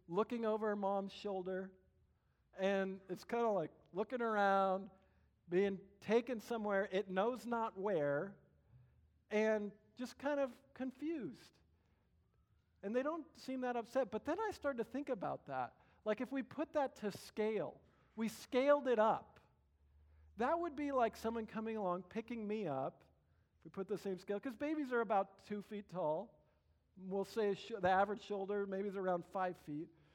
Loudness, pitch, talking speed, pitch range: -40 LUFS, 210 Hz, 160 wpm, 190-240 Hz